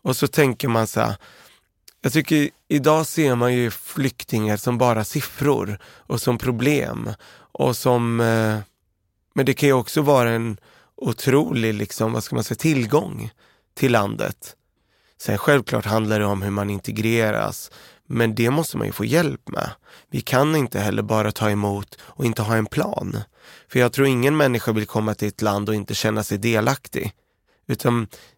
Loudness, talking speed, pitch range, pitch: -21 LUFS, 170 wpm, 110-135 Hz, 115 Hz